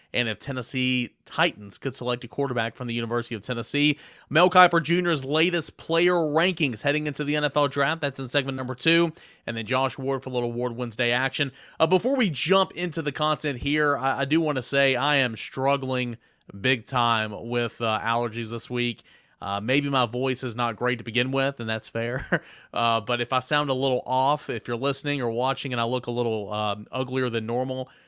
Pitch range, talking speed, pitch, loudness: 120-145 Hz, 210 wpm, 130 Hz, -25 LUFS